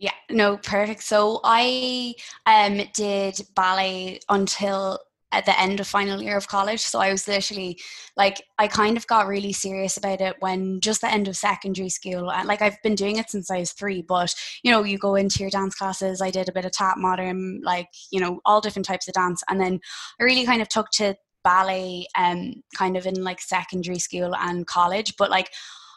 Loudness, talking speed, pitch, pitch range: -23 LUFS, 215 wpm, 195 Hz, 185-210 Hz